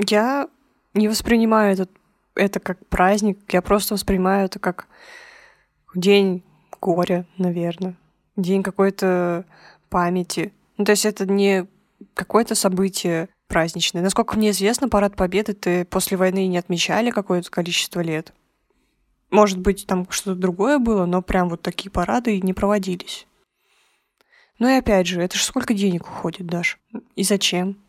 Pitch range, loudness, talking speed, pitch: 180-210 Hz, -20 LUFS, 140 wpm, 195 Hz